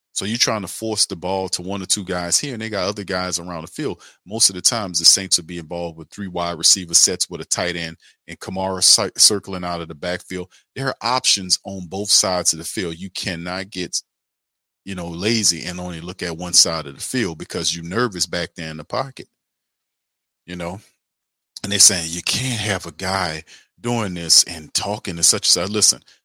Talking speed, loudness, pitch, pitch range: 220 wpm, -18 LUFS, 90 Hz, 85-100 Hz